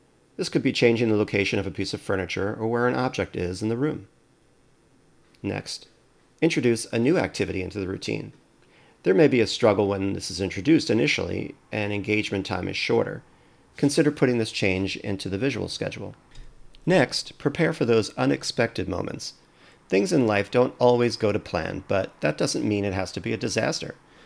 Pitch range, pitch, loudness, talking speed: 95-120 Hz, 105 Hz, -24 LUFS, 185 wpm